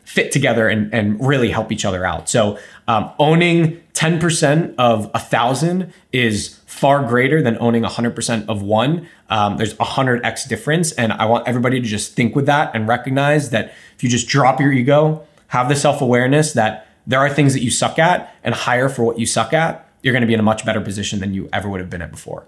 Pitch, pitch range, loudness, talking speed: 120 Hz, 110-145 Hz, -17 LUFS, 220 wpm